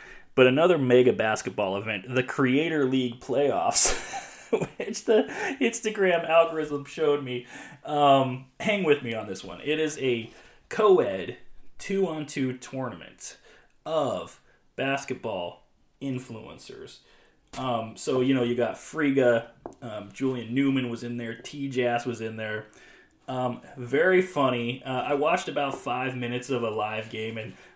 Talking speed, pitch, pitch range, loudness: 135 wpm, 130 Hz, 120-140 Hz, -26 LUFS